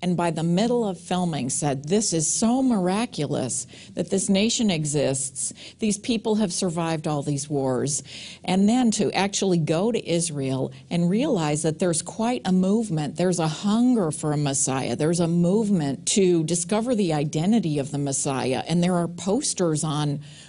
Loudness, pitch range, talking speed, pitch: -23 LUFS, 150-200 Hz, 165 wpm, 170 Hz